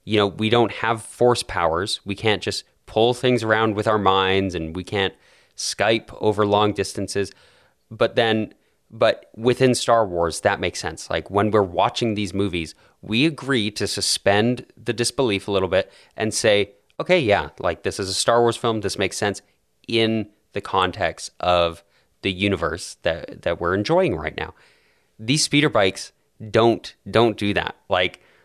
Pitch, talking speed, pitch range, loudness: 105 Hz, 170 wpm, 100-115 Hz, -21 LUFS